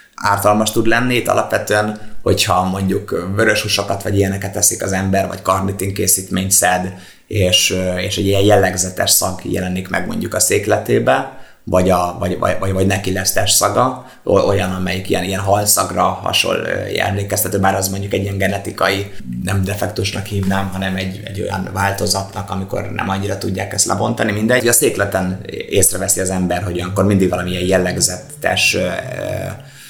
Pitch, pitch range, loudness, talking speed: 95 Hz, 95-100 Hz, -16 LUFS, 155 wpm